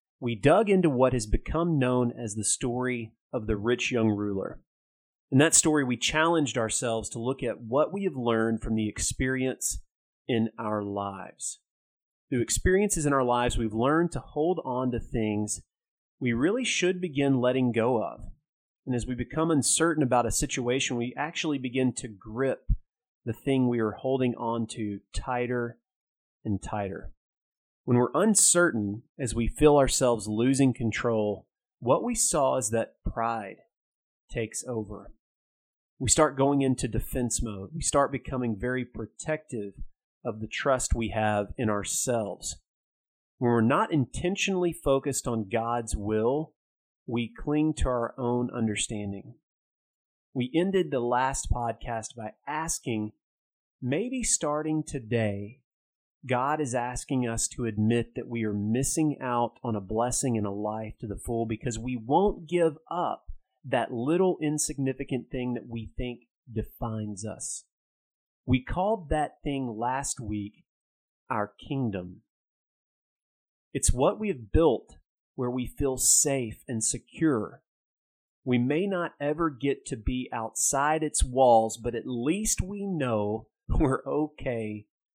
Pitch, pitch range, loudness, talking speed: 125 Hz, 115-145 Hz, -28 LUFS, 145 wpm